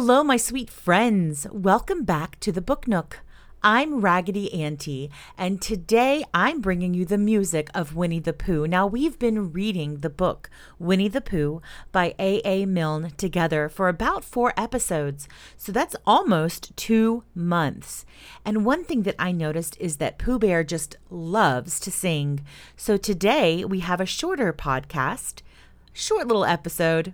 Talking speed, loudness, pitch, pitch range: 155 wpm, -24 LUFS, 185 Hz, 165-215 Hz